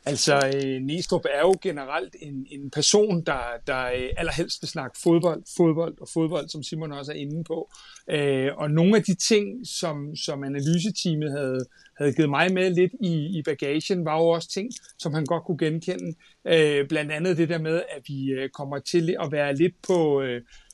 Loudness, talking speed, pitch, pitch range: -25 LUFS, 180 wpm, 160 Hz, 140-175 Hz